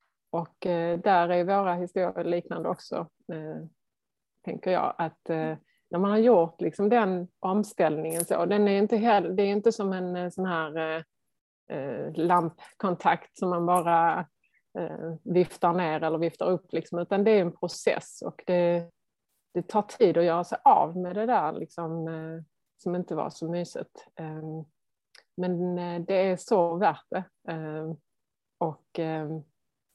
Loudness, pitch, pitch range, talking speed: -27 LUFS, 175 Hz, 165-185 Hz, 160 wpm